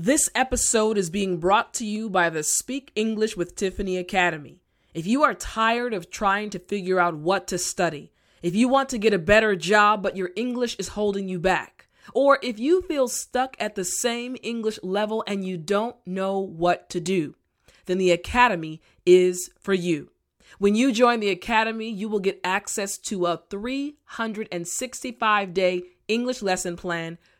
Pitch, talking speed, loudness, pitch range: 200 Hz, 175 wpm, -24 LUFS, 180-230 Hz